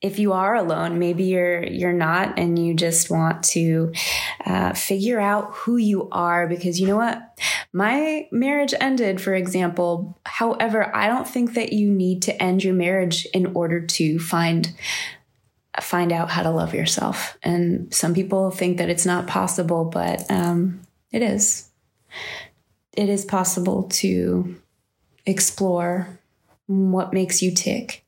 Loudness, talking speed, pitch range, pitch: -21 LUFS, 150 wpm, 175-200 Hz, 185 Hz